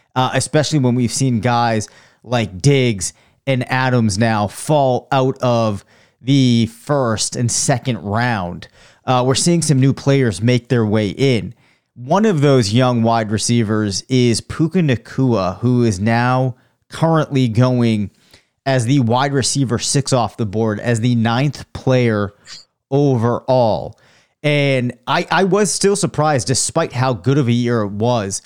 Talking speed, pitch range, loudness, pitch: 150 wpm, 115-135 Hz, -16 LUFS, 125 Hz